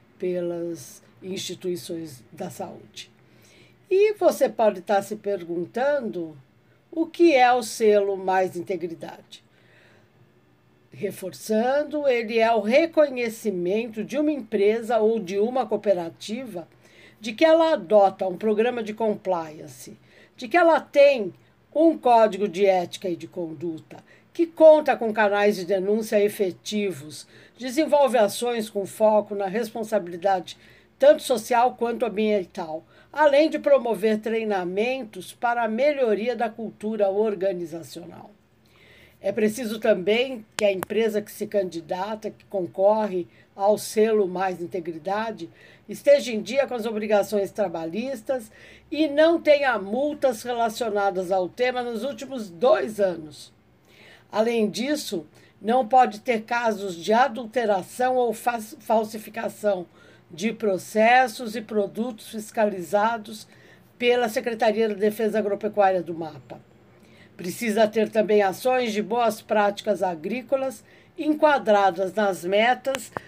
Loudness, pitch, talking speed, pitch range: -23 LUFS, 215 Hz, 115 wpm, 195-245 Hz